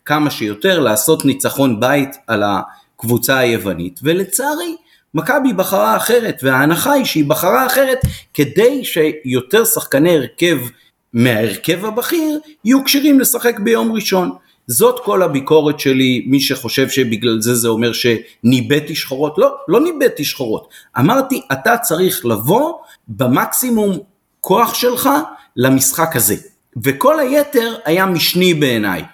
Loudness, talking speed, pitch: -14 LUFS, 120 wpm, 165 Hz